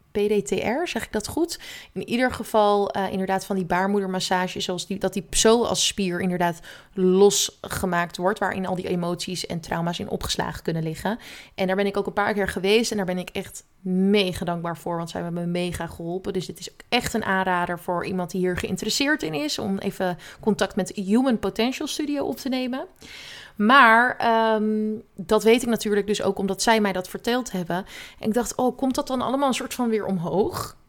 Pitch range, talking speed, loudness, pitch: 185-225 Hz, 210 wpm, -23 LUFS, 200 Hz